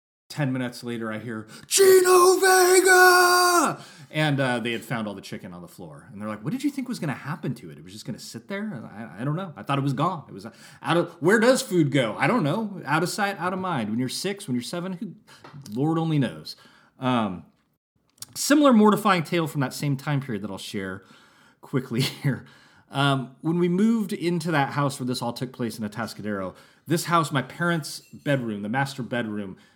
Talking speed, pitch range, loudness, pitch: 230 wpm, 120-185 Hz, -23 LUFS, 145 Hz